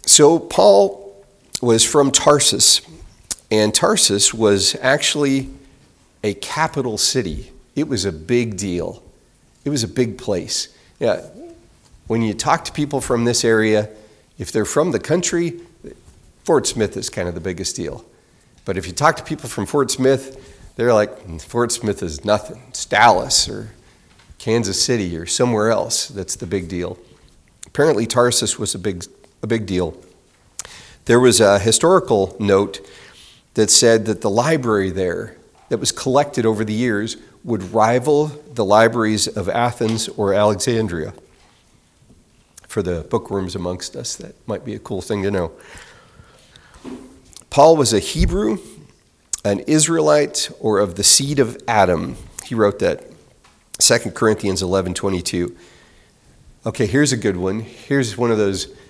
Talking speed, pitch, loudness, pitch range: 150 wpm, 110 Hz, -17 LUFS, 100-125 Hz